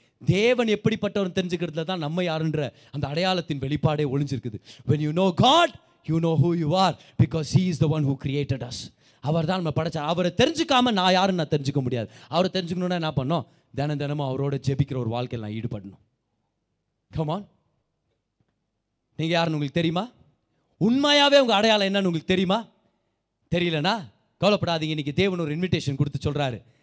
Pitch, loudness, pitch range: 160 Hz, -24 LUFS, 140-185 Hz